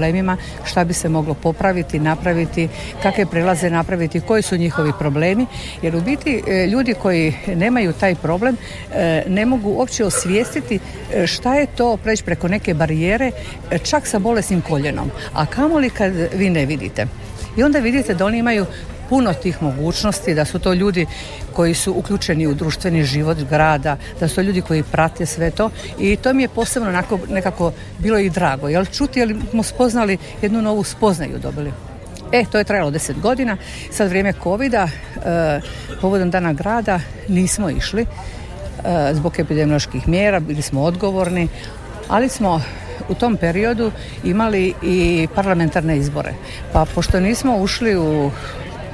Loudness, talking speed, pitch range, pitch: -18 LUFS, 155 wpm, 160-210 Hz, 180 Hz